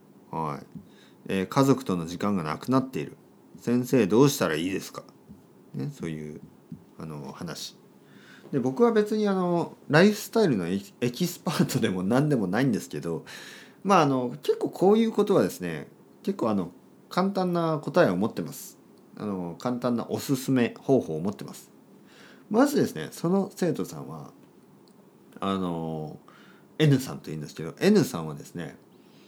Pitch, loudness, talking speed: 135 Hz, -26 LUFS, 310 characters per minute